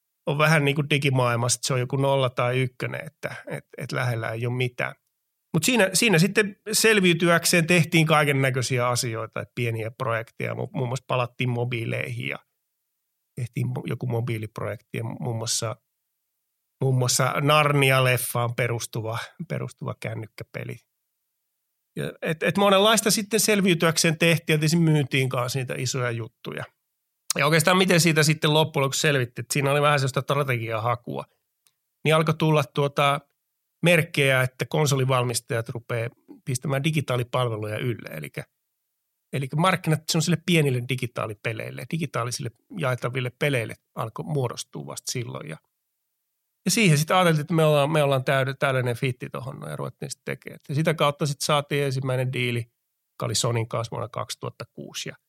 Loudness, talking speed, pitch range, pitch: -23 LUFS, 140 wpm, 125-155 Hz, 135 Hz